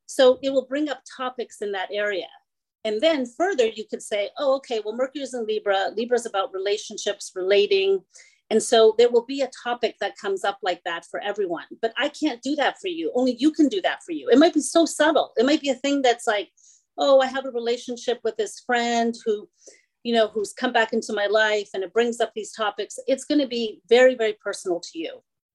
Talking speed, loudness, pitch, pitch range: 230 wpm, -23 LUFS, 235 Hz, 210-275 Hz